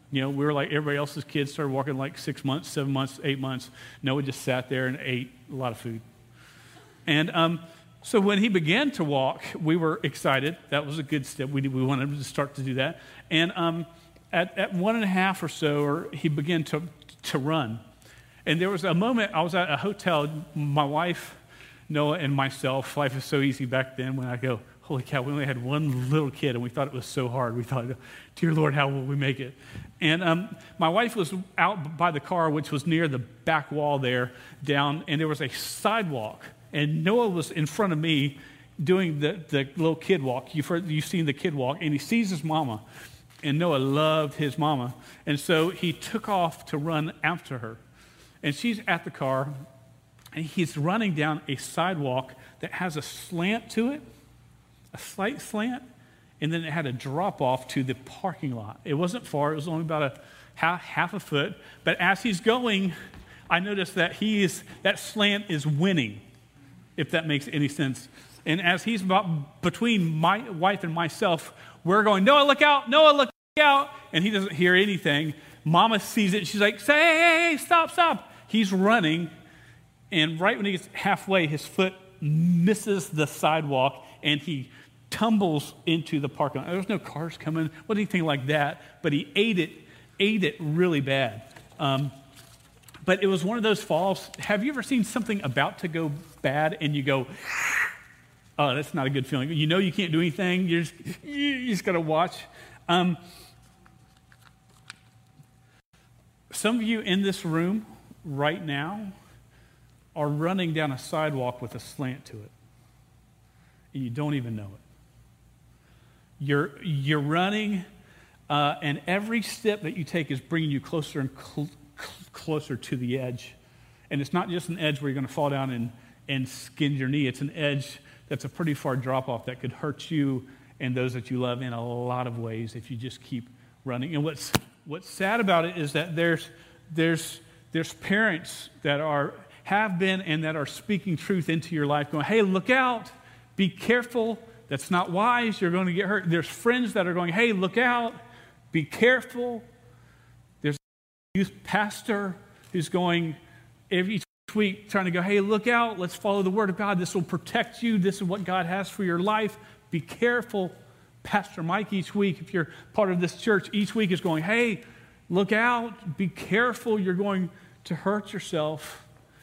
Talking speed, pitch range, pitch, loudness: 190 wpm, 135-190 Hz, 155 Hz, -26 LUFS